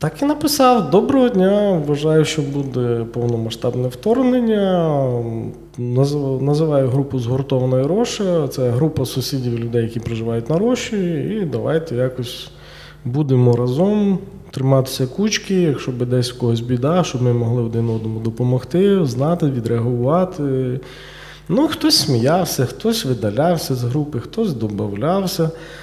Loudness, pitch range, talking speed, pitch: -18 LUFS, 125-180 Hz, 120 wpm, 140 Hz